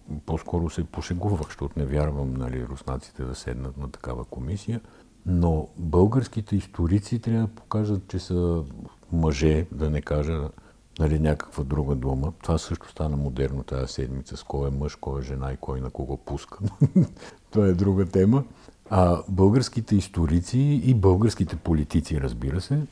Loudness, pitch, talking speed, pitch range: -26 LUFS, 80 Hz, 155 wpm, 70-100 Hz